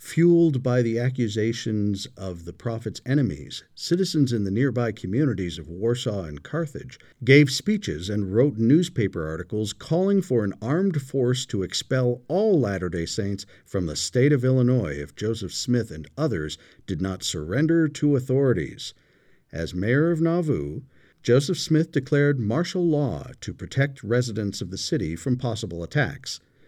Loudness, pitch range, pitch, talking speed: -24 LUFS, 95-145 Hz, 120 Hz, 150 wpm